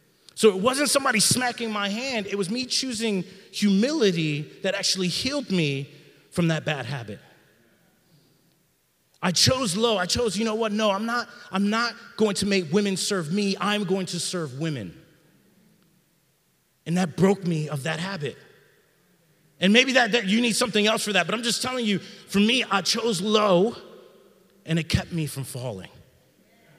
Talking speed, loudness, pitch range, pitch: 170 wpm, -24 LUFS, 170-225 Hz, 195 Hz